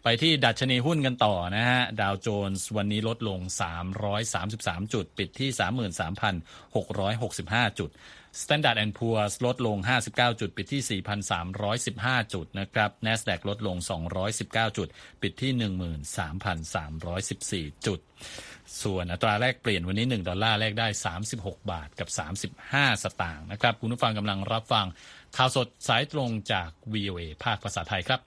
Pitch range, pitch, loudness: 95-115 Hz, 105 Hz, -28 LUFS